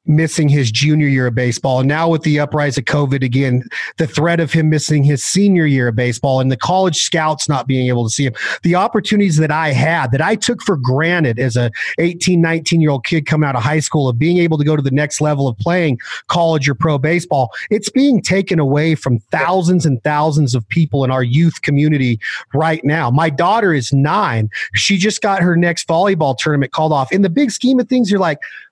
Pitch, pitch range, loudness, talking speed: 155 Hz, 135-170 Hz, -15 LUFS, 225 wpm